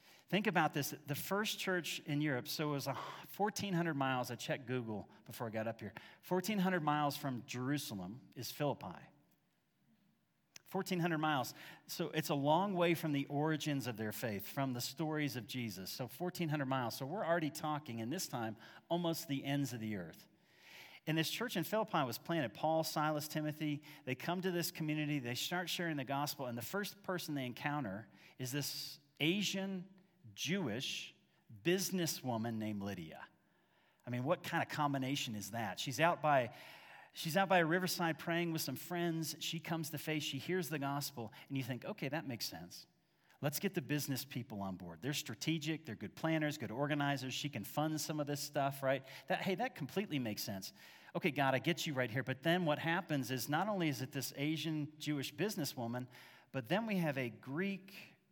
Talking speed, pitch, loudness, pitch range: 190 wpm, 150 Hz, -39 LUFS, 130-170 Hz